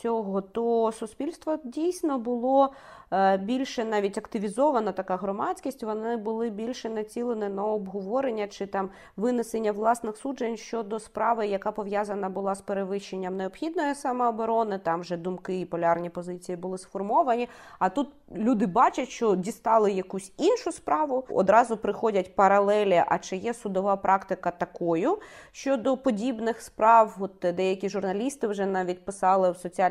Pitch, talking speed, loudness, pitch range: 215 Hz, 135 wpm, -27 LUFS, 195-240 Hz